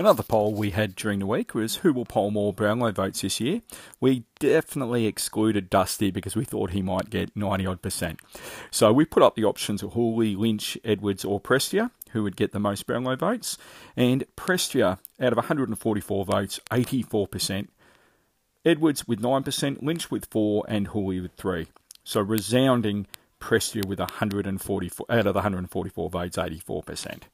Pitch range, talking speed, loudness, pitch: 100-120 Hz, 165 wpm, -26 LUFS, 105 Hz